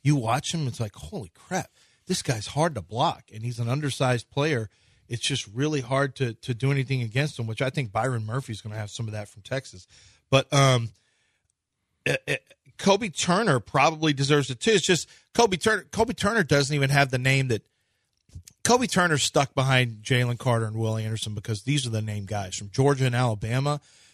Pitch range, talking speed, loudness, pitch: 115-145 Hz, 200 wpm, -25 LUFS, 130 Hz